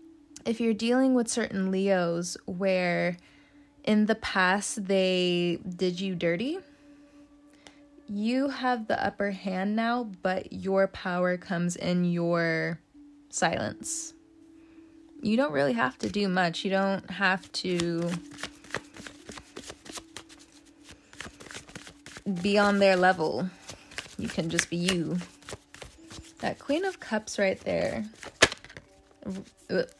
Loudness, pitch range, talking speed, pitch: -28 LUFS, 185-290 Hz, 105 wpm, 200 Hz